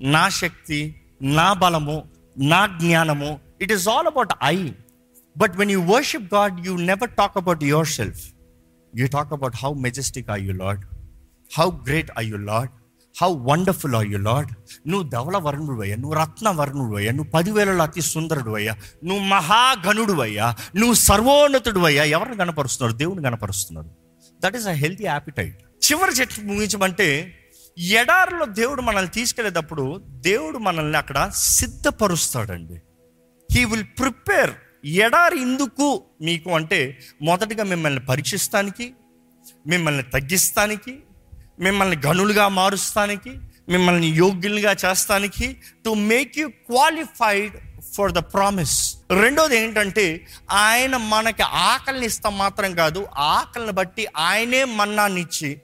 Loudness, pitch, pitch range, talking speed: -20 LUFS, 175 Hz, 135-210 Hz, 125 wpm